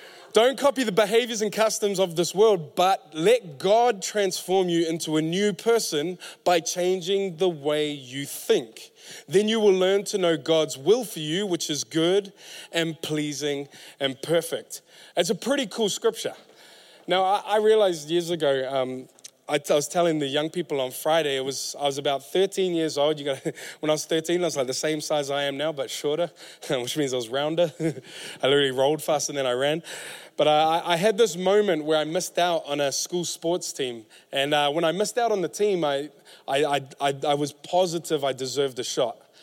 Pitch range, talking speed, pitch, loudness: 145-195 Hz, 205 wpm, 165 Hz, -24 LUFS